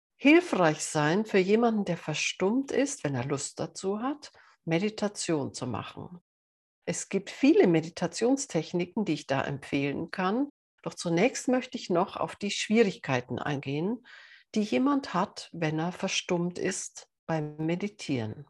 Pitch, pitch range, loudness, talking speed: 175 Hz, 155-220 Hz, -29 LUFS, 135 wpm